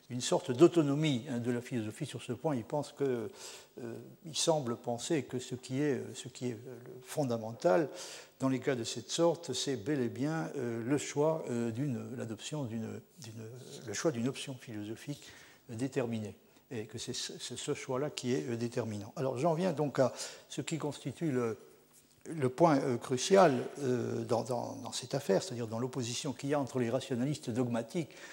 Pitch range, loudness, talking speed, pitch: 120-145 Hz, -34 LUFS, 170 wpm, 130 Hz